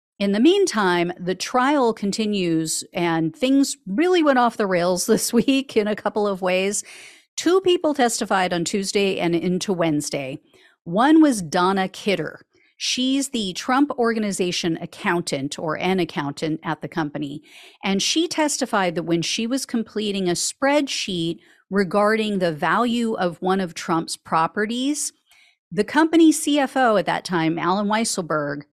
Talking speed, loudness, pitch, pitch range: 145 wpm, -21 LUFS, 200 Hz, 175-245 Hz